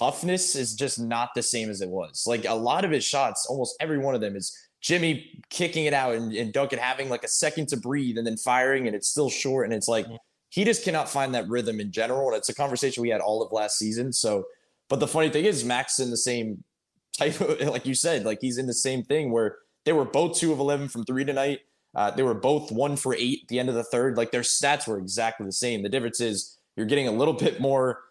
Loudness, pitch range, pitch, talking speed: -26 LUFS, 115-145 Hz, 130 Hz, 260 wpm